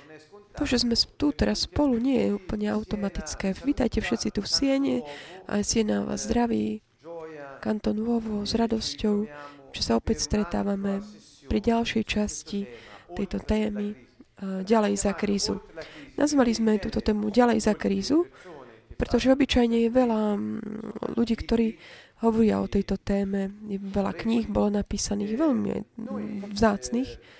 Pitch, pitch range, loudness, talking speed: 215 Hz, 200-230 Hz, -26 LUFS, 125 wpm